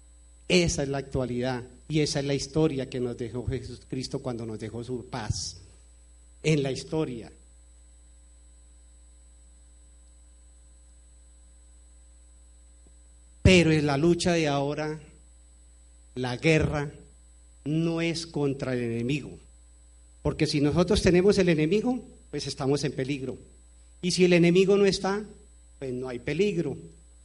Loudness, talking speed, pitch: -26 LUFS, 120 wpm, 120 Hz